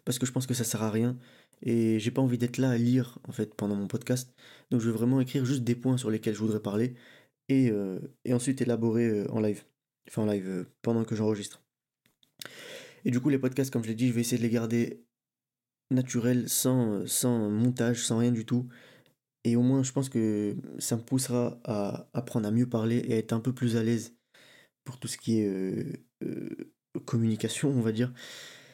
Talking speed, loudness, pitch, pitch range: 220 wpm, -29 LUFS, 120 Hz, 110-125 Hz